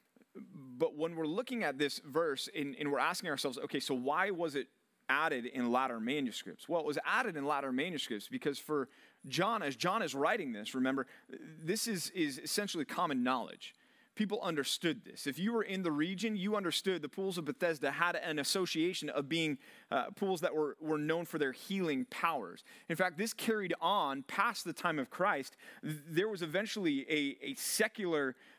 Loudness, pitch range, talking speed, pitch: -36 LUFS, 145-200 Hz, 185 wpm, 165 Hz